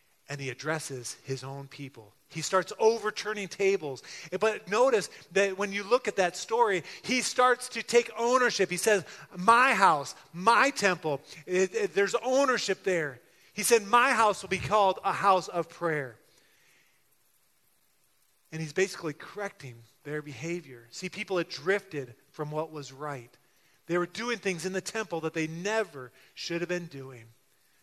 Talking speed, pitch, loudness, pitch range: 160 wpm, 185 Hz, -28 LUFS, 150-215 Hz